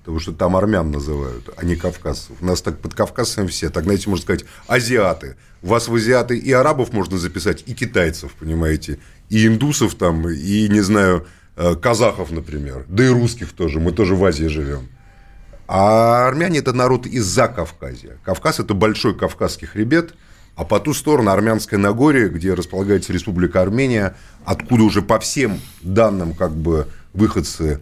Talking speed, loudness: 165 wpm, -18 LUFS